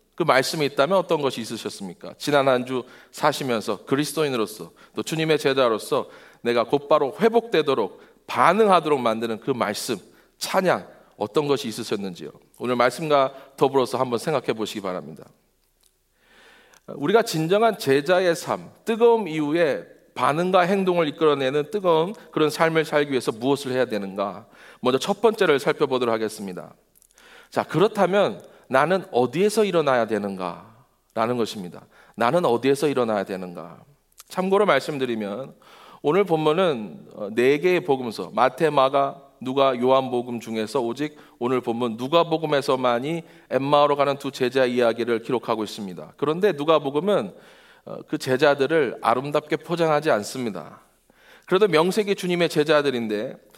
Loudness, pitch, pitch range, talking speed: -22 LUFS, 145 Hz, 125-165 Hz, 335 characters per minute